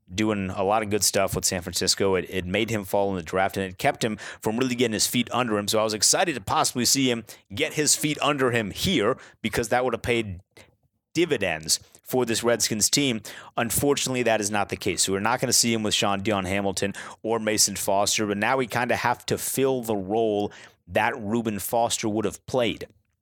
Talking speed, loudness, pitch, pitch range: 225 wpm, -24 LUFS, 110 Hz, 100-120 Hz